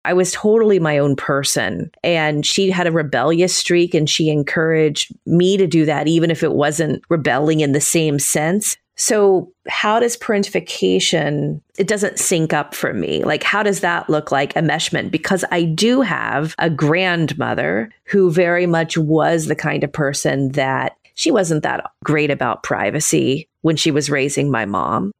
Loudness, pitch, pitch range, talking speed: -17 LUFS, 160 Hz, 150-180 Hz, 175 wpm